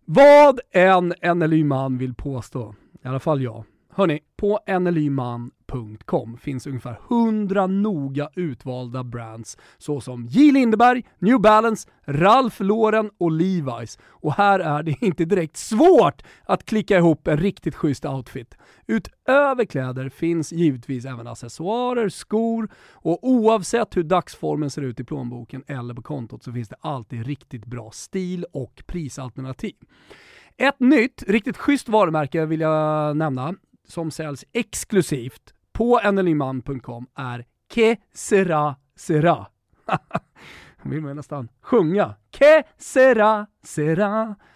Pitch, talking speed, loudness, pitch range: 160 Hz, 125 wpm, -20 LUFS, 130-210 Hz